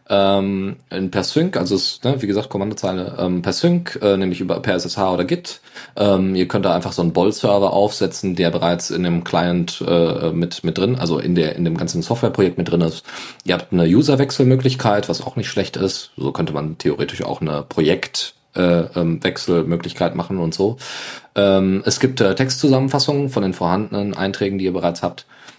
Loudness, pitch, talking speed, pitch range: -19 LUFS, 95 Hz, 190 wpm, 90-105 Hz